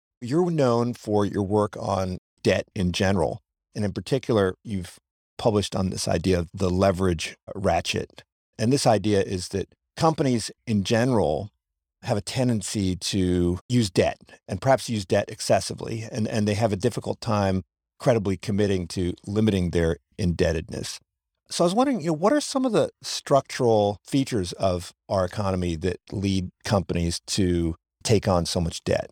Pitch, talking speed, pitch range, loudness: 100 Hz, 160 wpm, 90-120 Hz, -25 LUFS